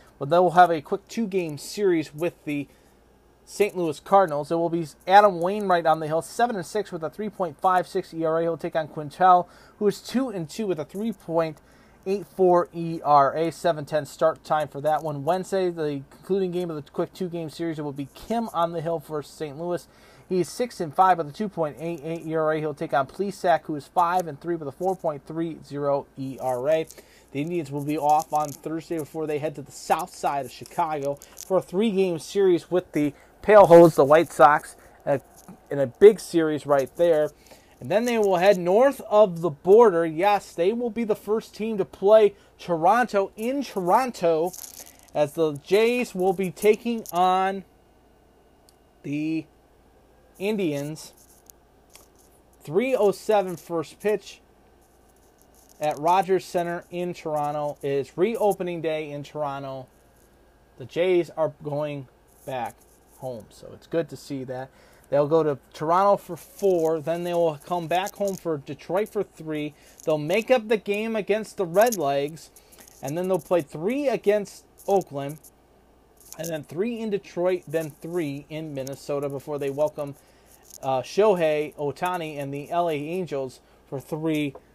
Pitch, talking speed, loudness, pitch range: 165 Hz, 160 wpm, -24 LUFS, 150-190 Hz